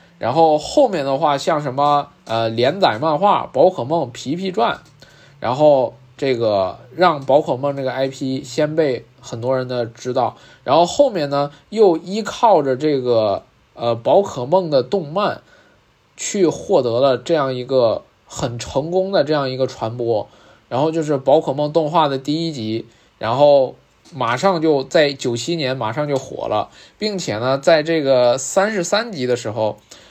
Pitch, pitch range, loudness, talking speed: 140 Hz, 130-165 Hz, -18 LUFS, 230 characters per minute